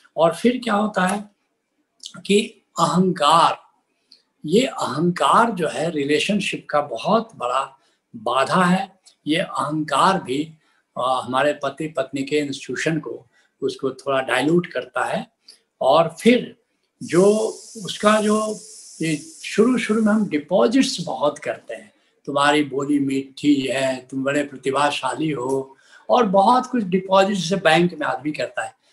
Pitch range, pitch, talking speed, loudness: 145-205 Hz, 160 Hz, 130 wpm, -20 LUFS